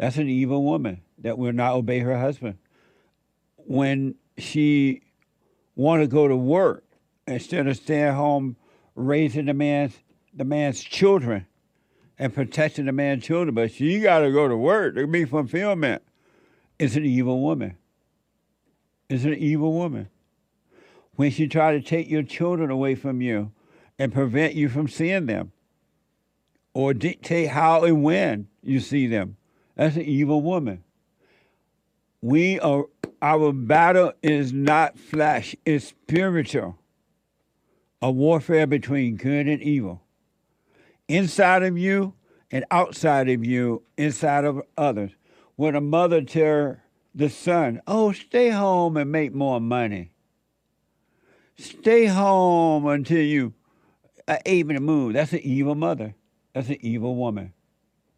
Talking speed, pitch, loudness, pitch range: 135 wpm, 145 Hz, -22 LUFS, 130-160 Hz